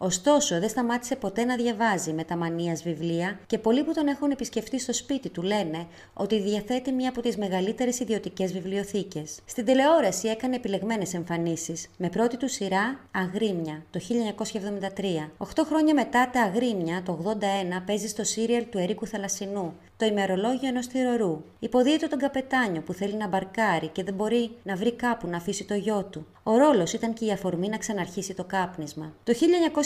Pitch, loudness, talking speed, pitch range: 210 Hz, -27 LUFS, 175 wpm, 185-240 Hz